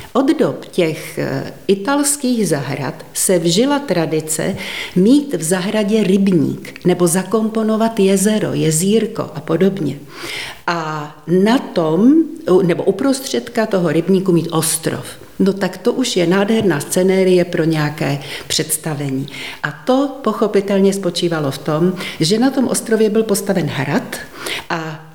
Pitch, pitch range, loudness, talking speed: 185 Hz, 160-220 Hz, -16 LUFS, 120 wpm